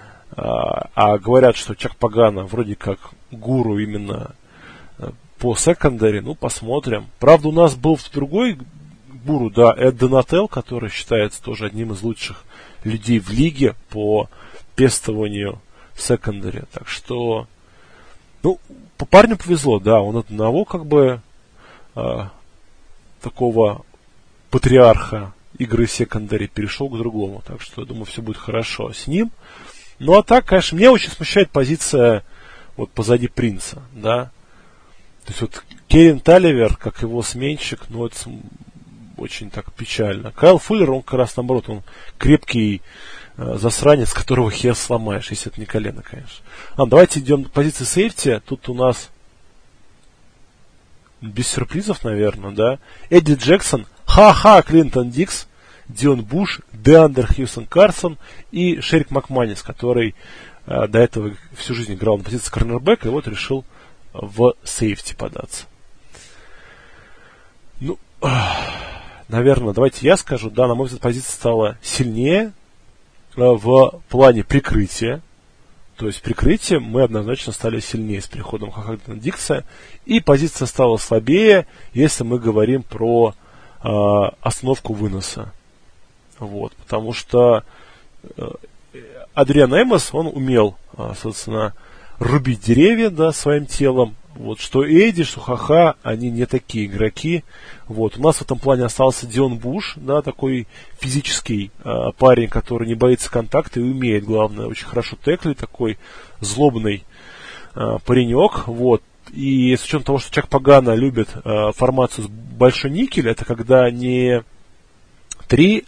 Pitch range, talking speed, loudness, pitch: 110-140 Hz, 135 wpm, -17 LUFS, 120 Hz